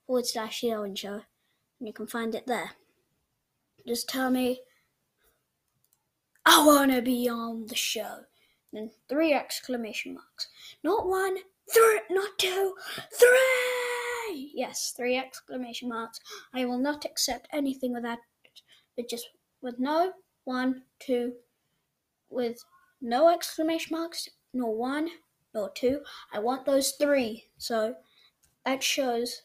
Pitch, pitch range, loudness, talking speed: 255 Hz, 235-325 Hz, -28 LUFS, 120 wpm